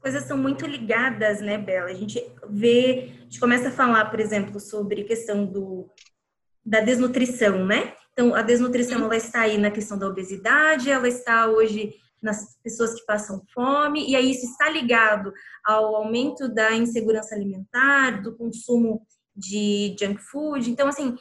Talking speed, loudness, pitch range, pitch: 160 wpm, -22 LUFS, 210-250 Hz, 225 Hz